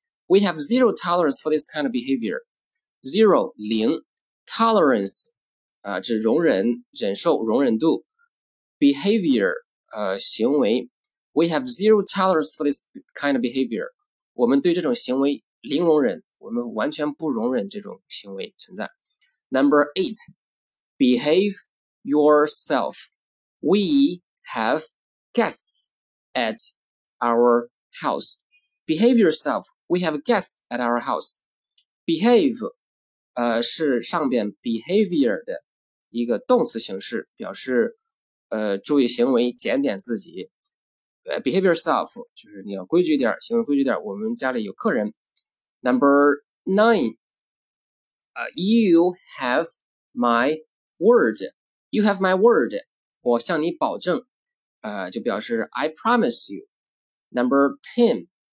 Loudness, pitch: -21 LUFS, 210 Hz